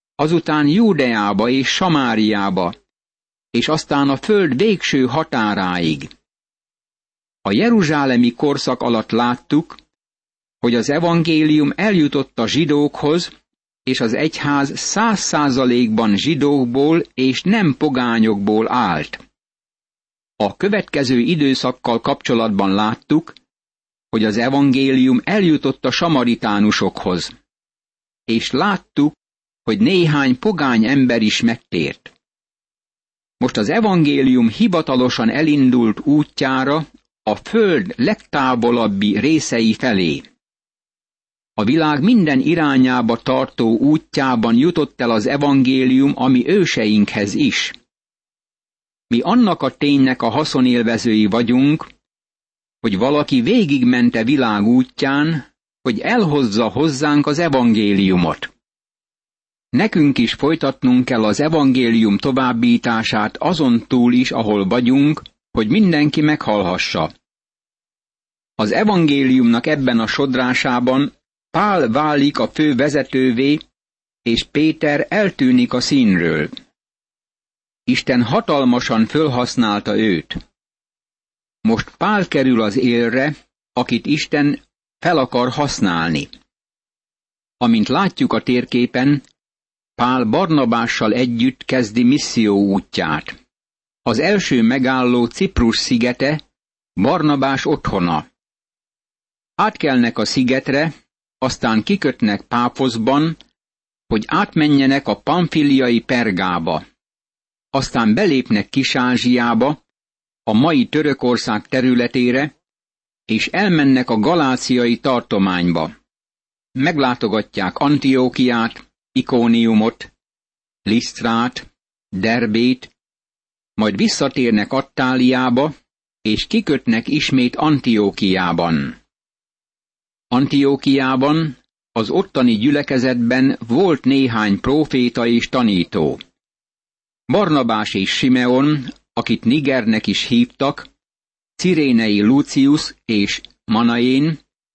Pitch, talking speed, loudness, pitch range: 130 Hz, 85 wpm, -16 LUFS, 120-150 Hz